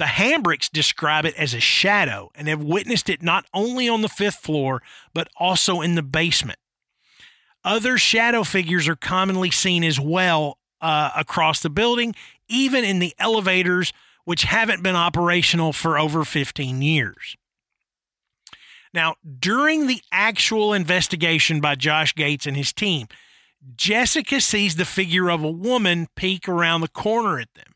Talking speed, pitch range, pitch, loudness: 150 wpm, 155-205 Hz, 175 Hz, -20 LUFS